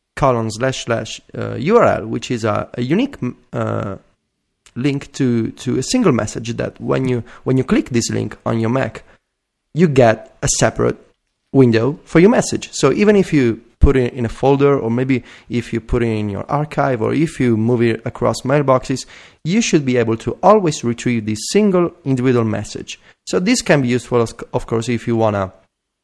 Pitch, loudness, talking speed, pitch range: 125 Hz, -17 LUFS, 195 wpm, 115-140 Hz